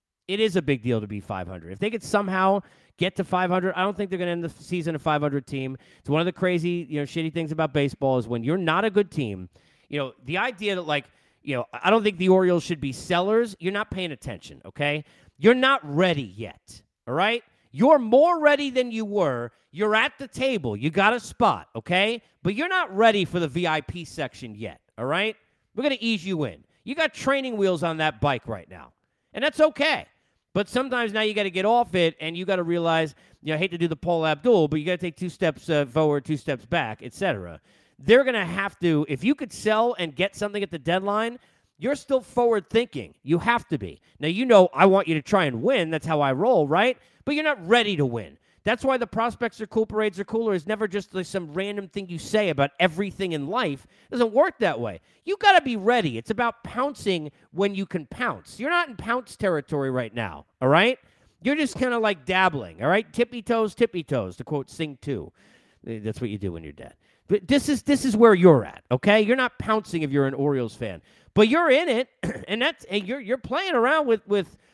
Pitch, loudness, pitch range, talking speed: 185 Hz, -24 LUFS, 145-225 Hz, 240 wpm